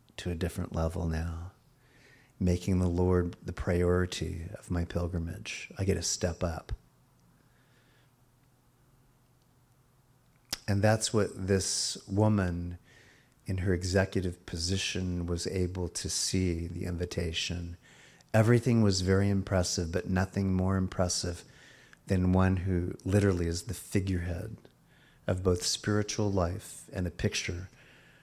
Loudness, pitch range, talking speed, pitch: -31 LUFS, 90-110 Hz, 115 wpm, 95 Hz